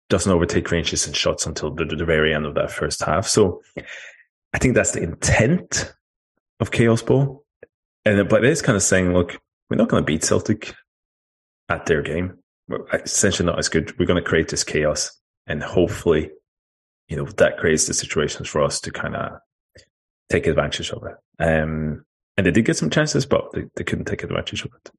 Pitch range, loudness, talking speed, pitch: 75-95 Hz, -21 LUFS, 200 wpm, 85 Hz